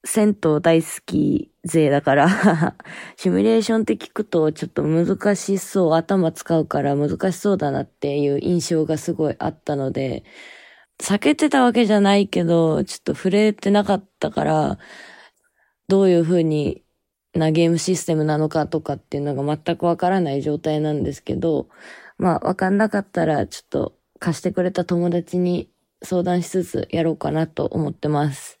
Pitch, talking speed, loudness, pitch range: 170 Hz, 340 characters per minute, -20 LUFS, 155-190 Hz